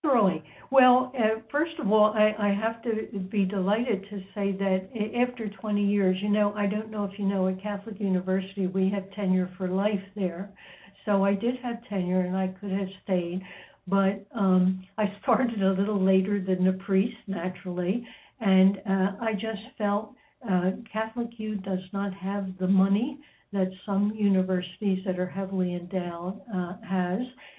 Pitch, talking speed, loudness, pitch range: 200 Hz, 170 wpm, -27 LUFS, 190-215 Hz